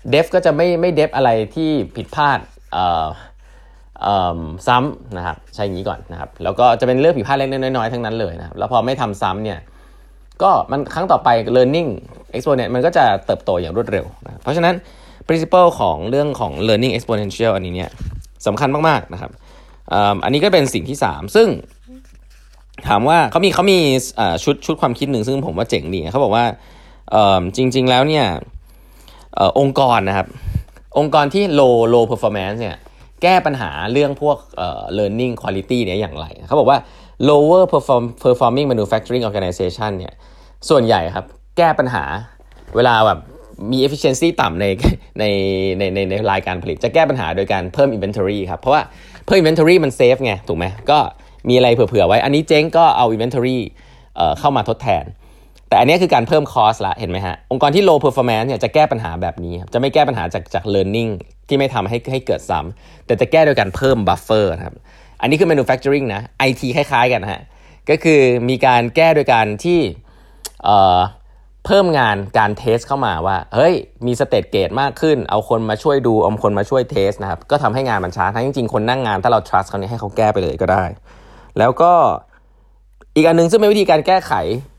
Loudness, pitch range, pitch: -16 LUFS, 100-145 Hz, 125 Hz